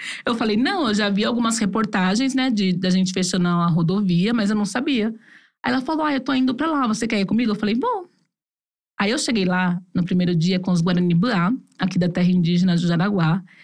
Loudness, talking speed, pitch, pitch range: -20 LUFS, 230 wpm, 205 Hz, 180-240 Hz